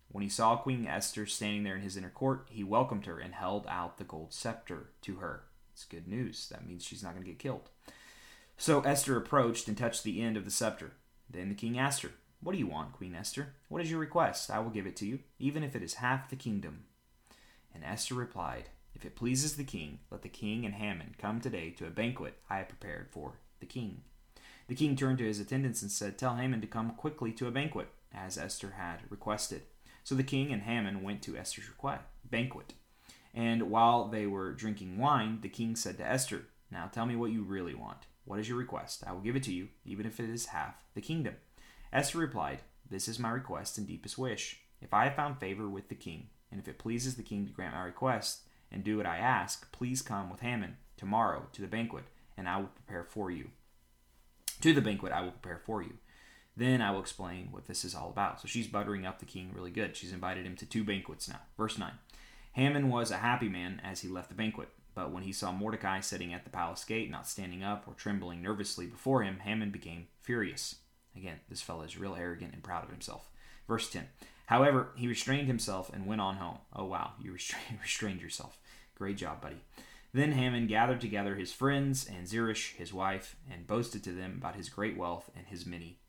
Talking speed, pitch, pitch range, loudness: 220 wpm, 105 Hz, 95-120 Hz, -36 LUFS